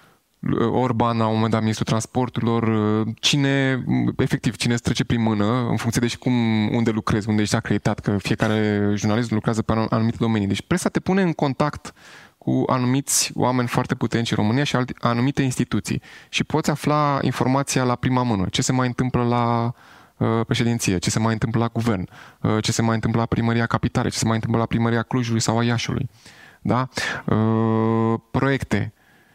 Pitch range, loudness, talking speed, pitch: 110-125 Hz, -21 LUFS, 180 wpm, 115 Hz